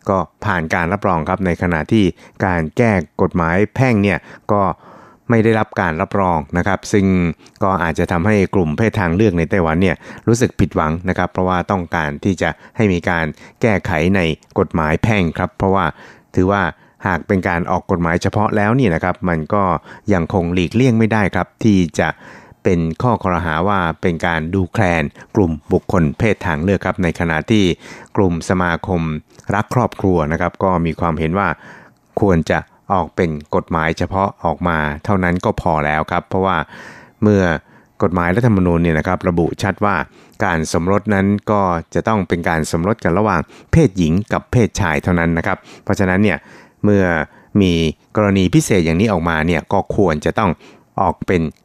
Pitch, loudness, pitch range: 90 Hz, -17 LUFS, 85-100 Hz